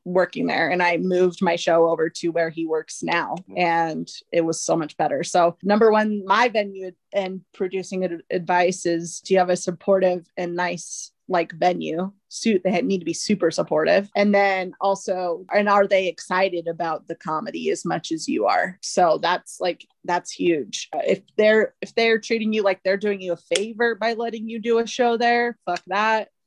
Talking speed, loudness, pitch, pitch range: 195 wpm, -22 LUFS, 185 Hz, 175-210 Hz